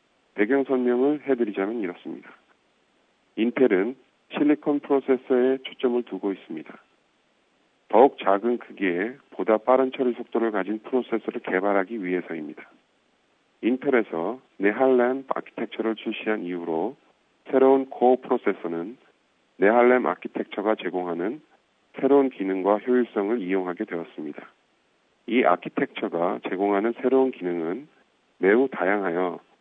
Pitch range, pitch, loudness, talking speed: 100-130 Hz, 115 Hz, -24 LUFS, 300 characters per minute